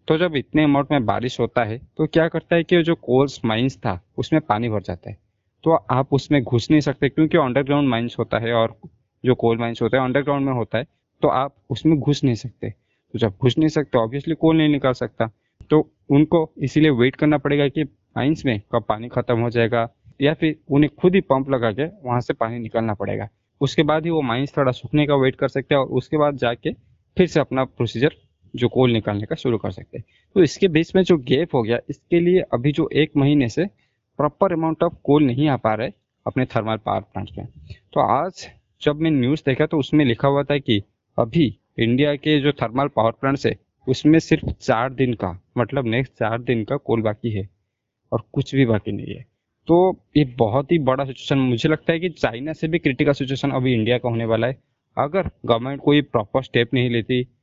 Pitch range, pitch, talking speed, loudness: 115-150 Hz, 130 Hz, 220 wpm, -20 LUFS